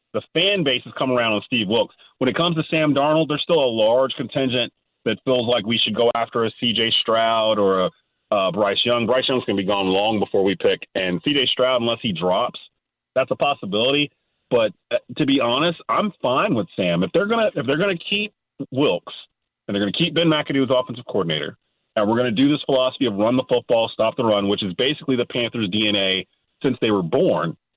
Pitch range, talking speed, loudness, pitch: 115-145 Hz, 230 wpm, -20 LUFS, 125 Hz